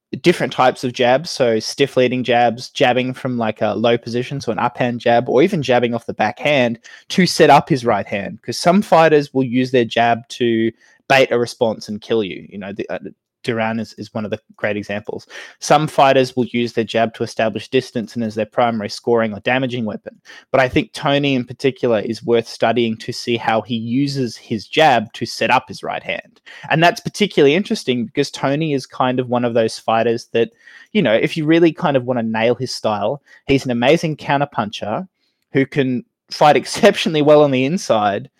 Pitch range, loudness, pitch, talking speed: 115-140 Hz, -17 LUFS, 125 Hz, 210 wpm